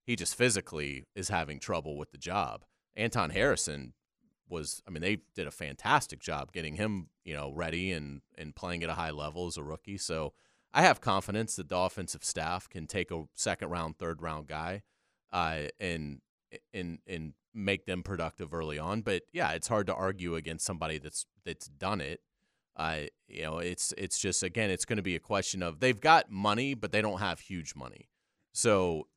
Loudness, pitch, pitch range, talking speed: -33 LUFS, 90 Hz, 80-95 Hz, 195 wpm